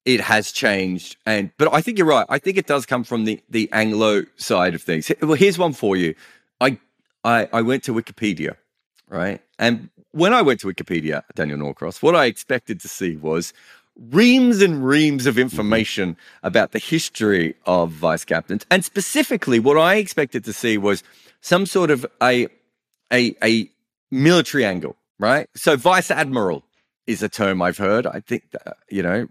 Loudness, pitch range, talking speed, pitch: -19 LUFS, 105-160 Hz, 180 wpm, 120 Hz